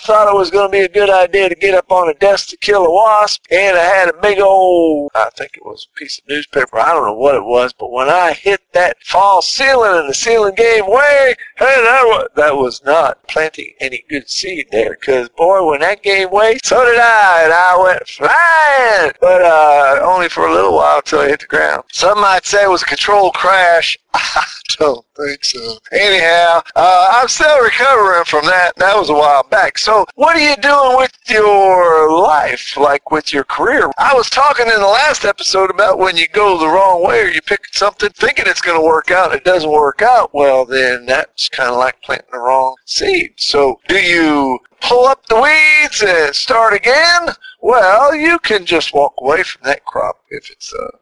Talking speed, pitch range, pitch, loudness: 215 wpm, 160-245 Hz, 195 Hz, -11 LUFS